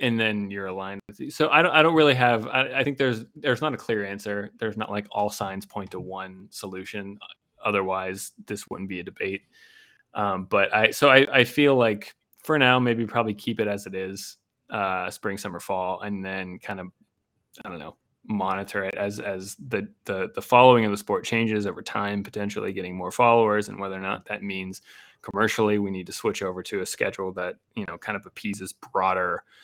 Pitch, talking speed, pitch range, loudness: 105 Hz, 215 wpm, 95-120 Hz, -24 LUFS